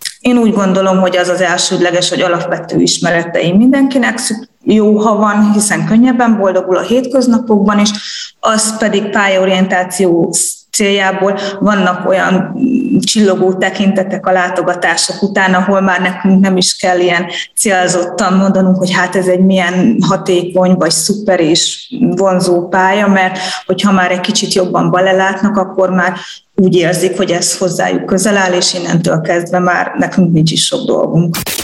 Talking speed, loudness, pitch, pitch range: 145 wpm, -11 LUFS, 190 Hz, 180-205 Hz